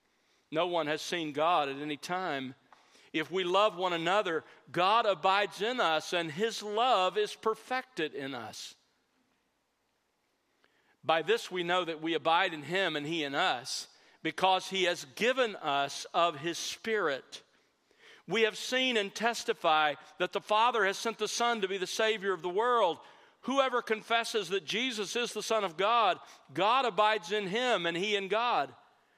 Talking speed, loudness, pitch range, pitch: 165 wpm, -31 LUFS, 165-220 Hz, 195 Hz